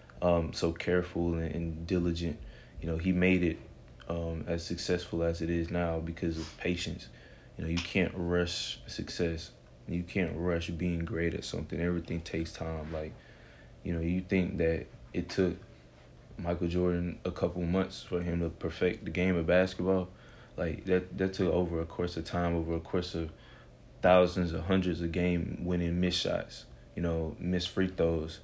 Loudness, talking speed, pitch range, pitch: -32 LUFS, 175 wpm, 80-90 Hz, 85 Hz